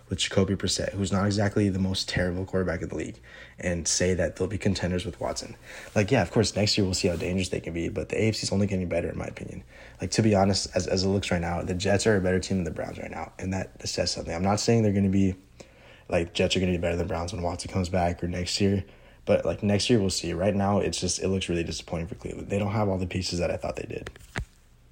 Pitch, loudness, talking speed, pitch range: 95 Hz, -27 LUFS, 285 wpm, 90-100 Hz